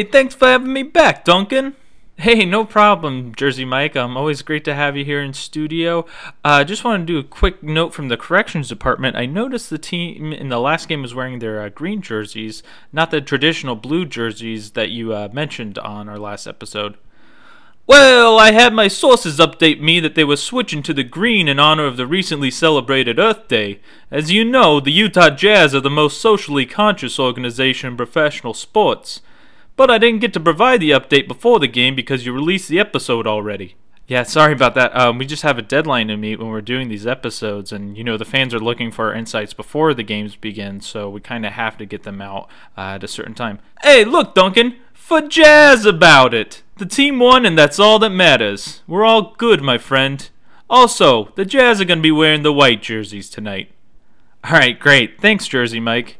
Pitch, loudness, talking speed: 145 Hz, -13 LUFS, 210 wpm